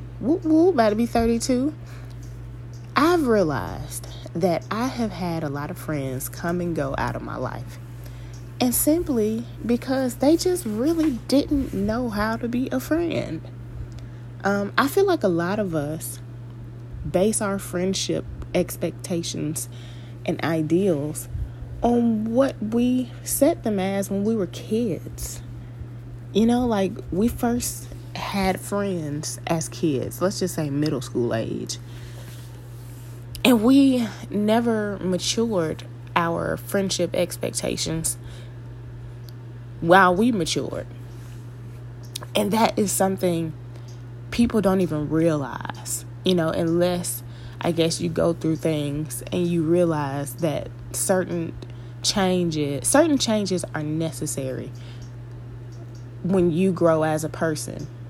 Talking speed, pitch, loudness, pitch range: 120 wpm, 155 Hz, -23 LUFS, 120-200 Hz